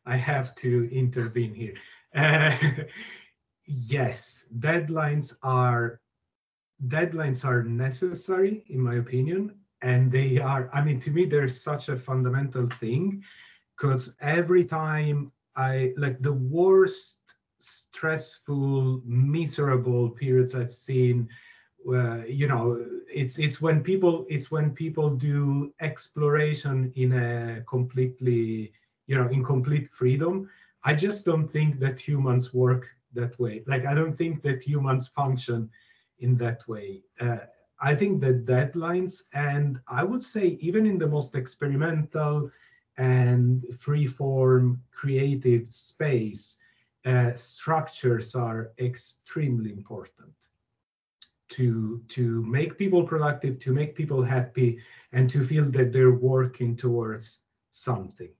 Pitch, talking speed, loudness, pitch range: 130 Hz, 120 wpm, -26 LUFS, 125-150 Hz